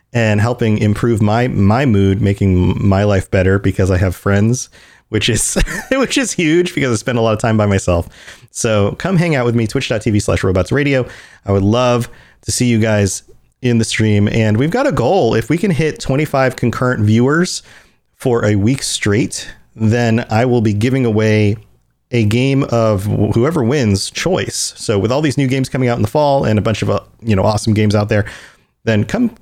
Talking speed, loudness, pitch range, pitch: 205 wpm, -15 LUFS, 105-125 Hz, 115 Hz